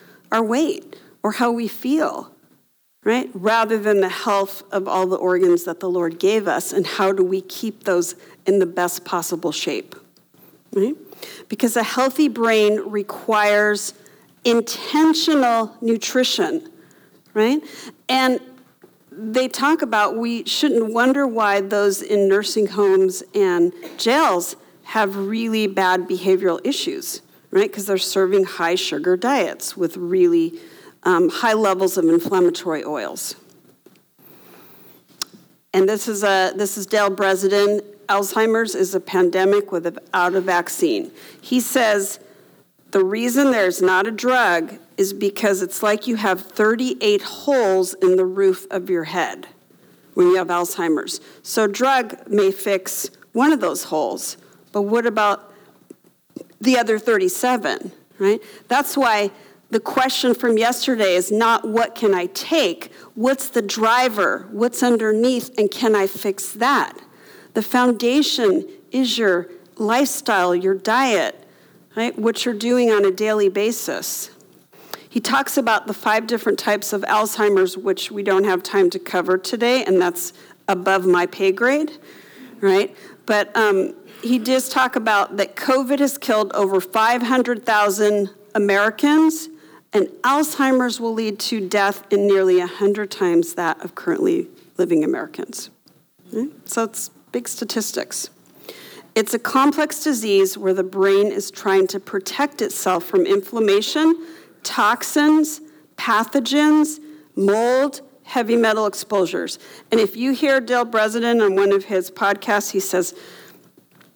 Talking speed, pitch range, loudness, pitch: 135 wpm, 195-260 Hz, -19 LUFS, 215 Hz